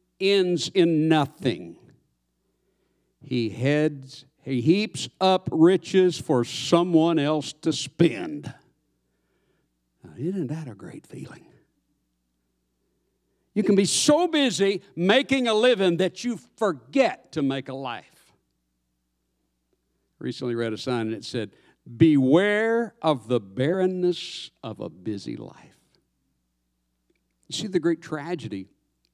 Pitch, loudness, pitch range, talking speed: 150 Hz, -23 LUFS, 110-180 Hz, 115 wpm